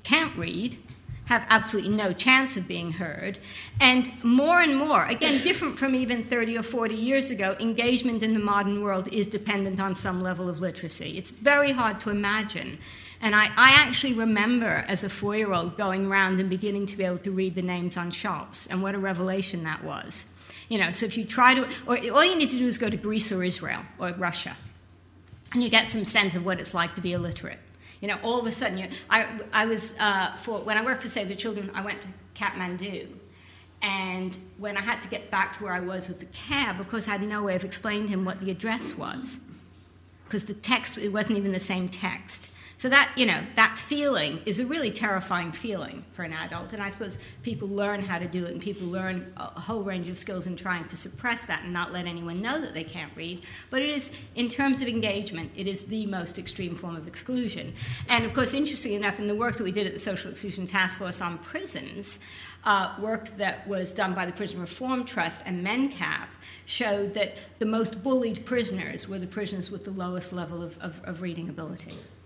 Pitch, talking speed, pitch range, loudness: 200 Hz, 225 wpm, 180-225 Hz, -26 LUFS